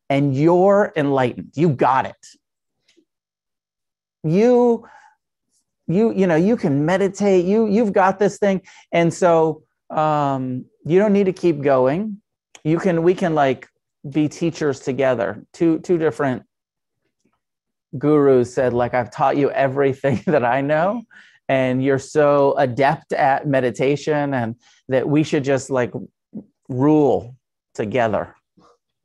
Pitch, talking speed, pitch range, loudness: 150 Hz, 130 wpm, 135-185 Hz, -19 LUFS